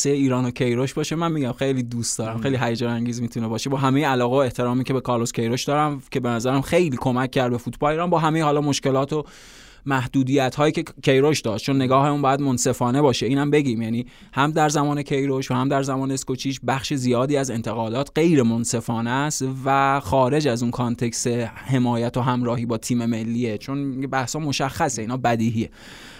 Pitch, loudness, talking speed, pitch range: 130 Hz, -22 LUFS, 190 wpm, 120-140 Hz